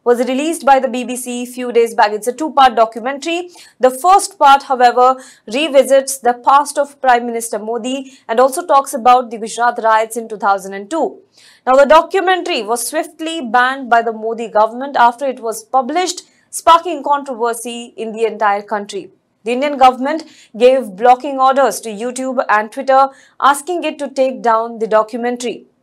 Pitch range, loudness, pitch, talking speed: 235-280 Hz, -14 LUFS, 255 Hz, 165 wpm